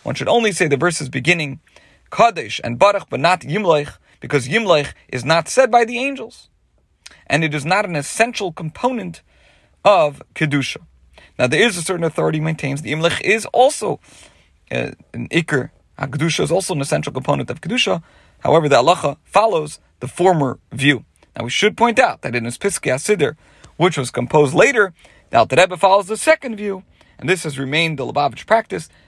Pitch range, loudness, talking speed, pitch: 140-195 Hz, -17 LUFS, 175 wpm, 160 Hz